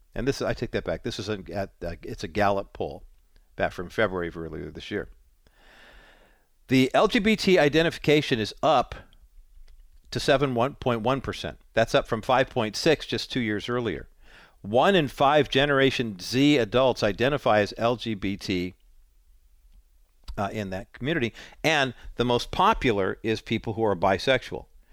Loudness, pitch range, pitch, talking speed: -25 LUFS, 95-130 Hz, 115 Hz, 140 wpm